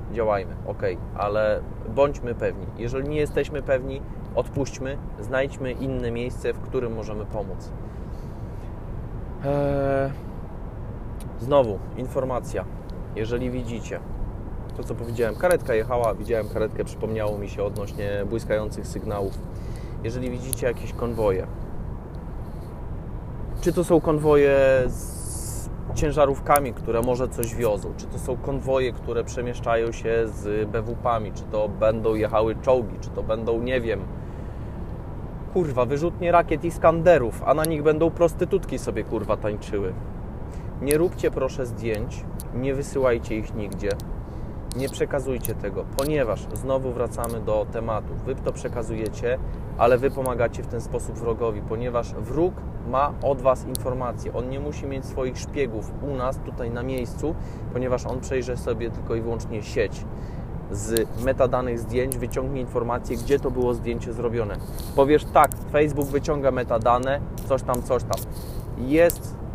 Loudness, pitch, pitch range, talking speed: -25 LUFS, 120 Hz, 110-135 Hz, 130 wpm